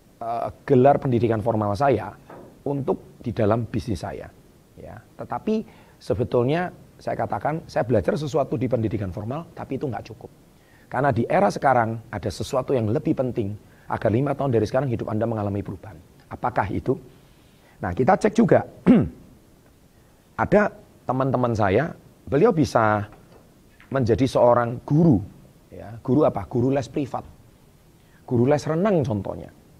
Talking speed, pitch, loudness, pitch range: 130 wpm, 120 Hz, -23 LUFS, 110-140 Hz